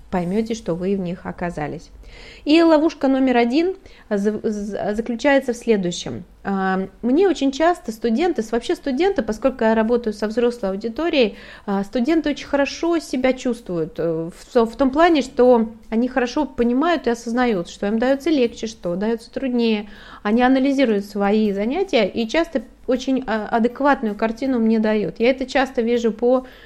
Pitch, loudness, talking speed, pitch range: 235 Hz, -20 LUFS, 140 wpm, 215-270 Hz